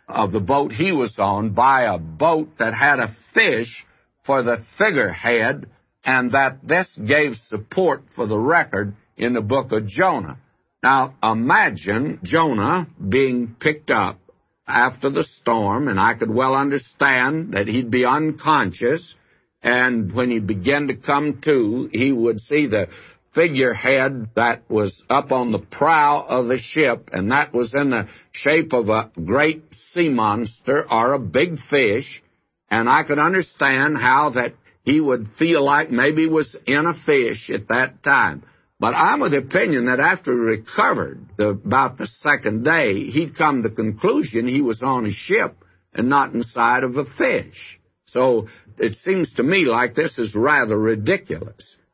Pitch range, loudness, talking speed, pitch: 110-145 Hz, -19 LUFS, 165 wpm, 130 Hz